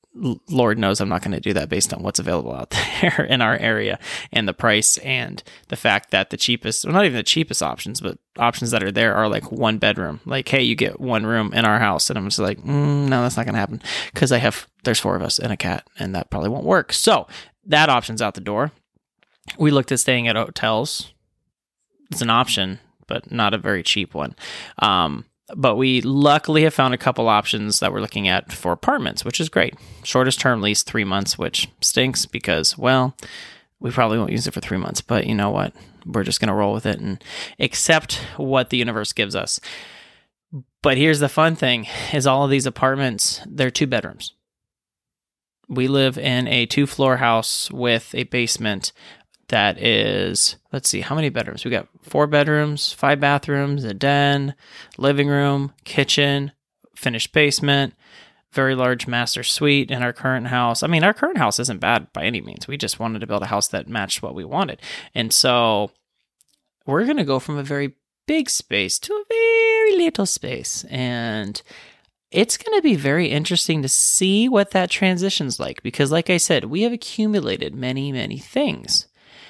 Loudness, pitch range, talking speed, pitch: -19 LUFS, 115-145 Hz, 195 wpm, 130 Hz